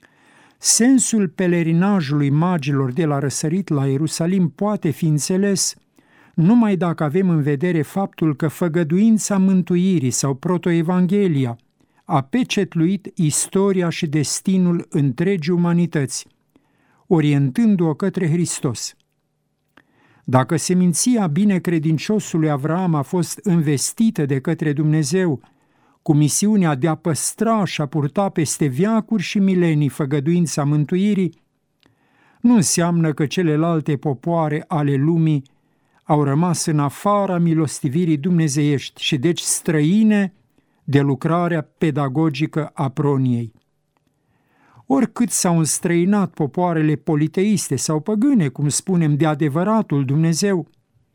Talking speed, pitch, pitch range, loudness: 105 wpm, 165 Hz, 150-185 Hz, -19 LUFS